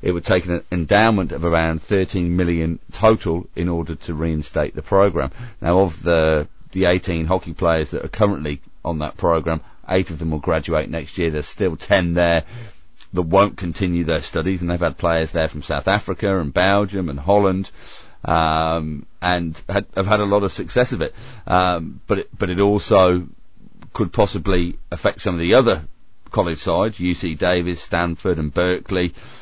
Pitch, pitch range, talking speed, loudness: 90 Hz, 80-95 Hz, 180 wpm, -20 LUFS